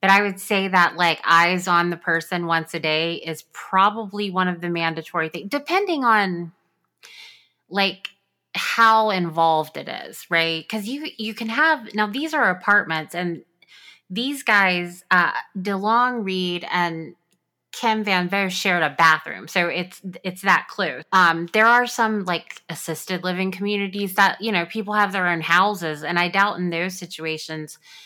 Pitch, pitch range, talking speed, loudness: 185 Hz, 170-205 Hz, 165 wpm, -20 LUFS